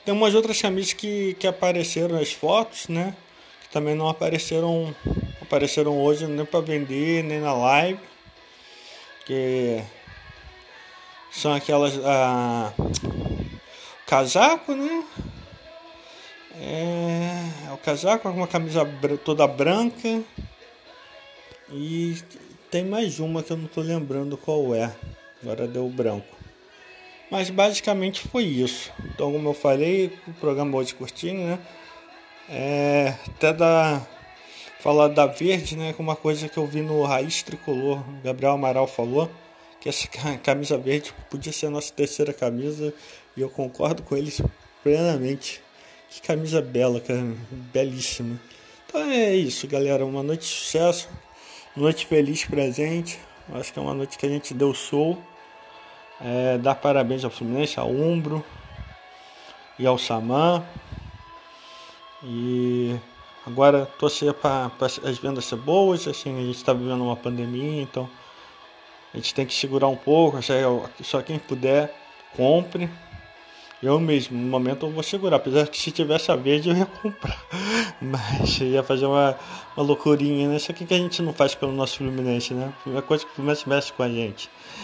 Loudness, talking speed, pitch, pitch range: -24 LUFS, 150 wpm, 145 Hz, 130-165 Hz